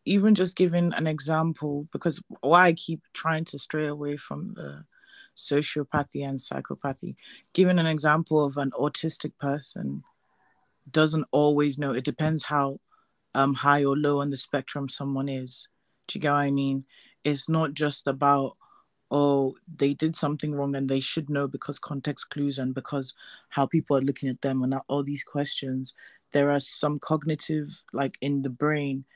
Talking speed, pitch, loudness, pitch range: 170 wpm, 145 Hz, -26 LUFS, 140-155 Hz